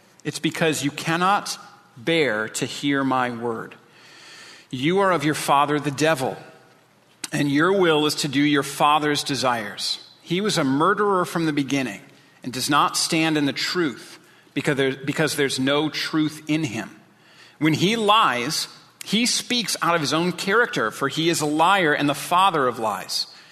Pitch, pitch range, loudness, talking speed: 150 Hz, 140-170 Hz, -21 LUFS, 170 wpm